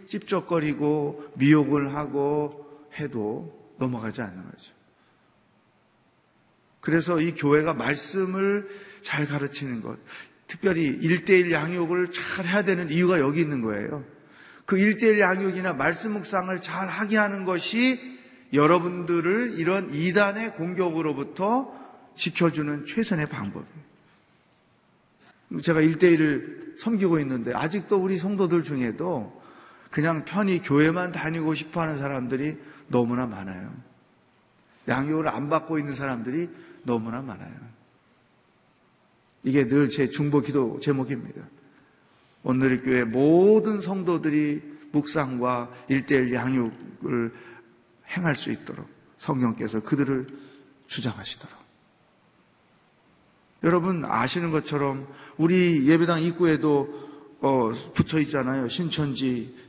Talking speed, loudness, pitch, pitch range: 255 characters per minute, -25 LUFS, 155 Hz, 140-180 Hz